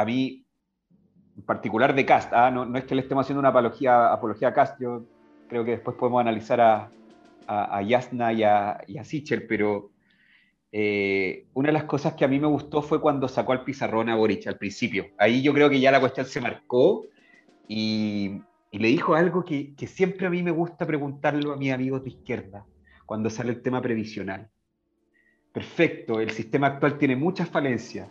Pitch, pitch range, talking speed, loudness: 125 Hz, 110-145 Hz, 195 wpm, -24 LUFS